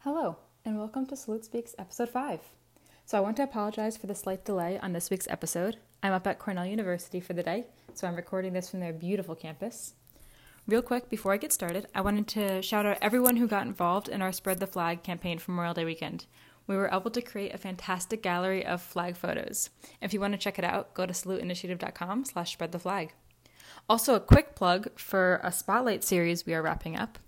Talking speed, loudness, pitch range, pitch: 210 wpm, -31 LUFS, 180-215 Hz, 195 Hz